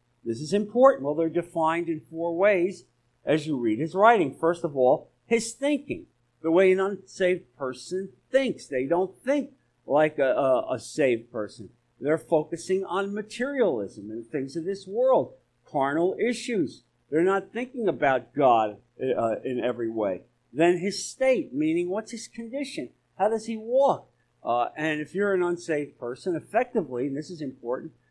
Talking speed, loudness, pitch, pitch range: 165 wpm, -26 LUFS, 170 Hz, 135-215 Hz